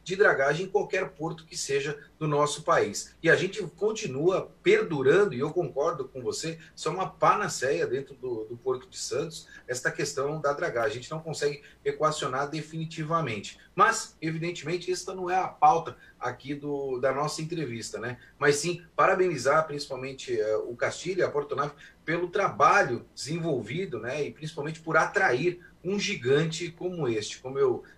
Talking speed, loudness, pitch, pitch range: 165 wpm, -28 LUFS, 165 Hz, 150-200 Hz